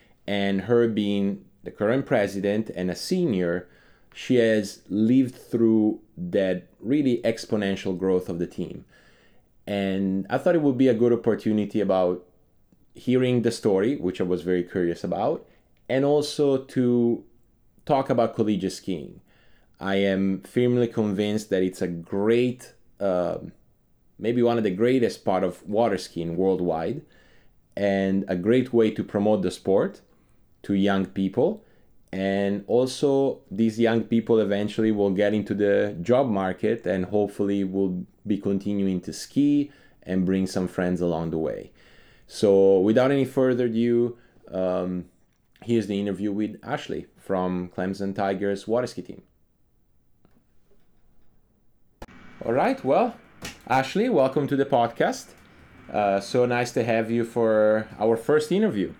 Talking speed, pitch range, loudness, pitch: 140 wpm, 95-120 Hz, -24 LUFS, 105 Hz